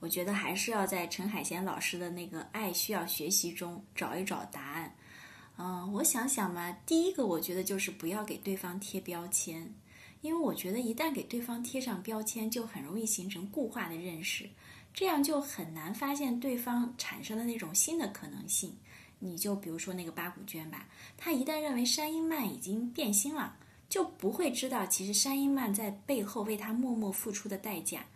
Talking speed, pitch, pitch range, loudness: 290 characters per minute, 210 Hz, 180-250 Hz, -34 LUFS